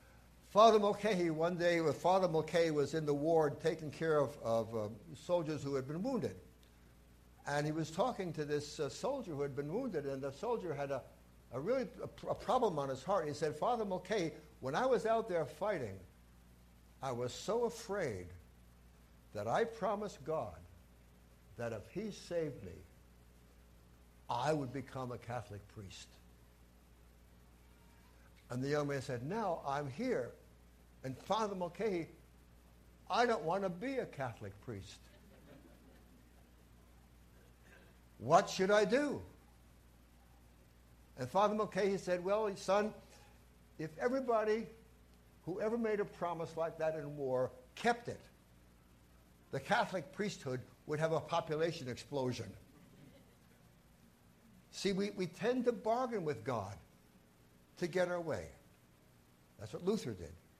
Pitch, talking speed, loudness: 130 Hz, 140 wpm, -37 LUFS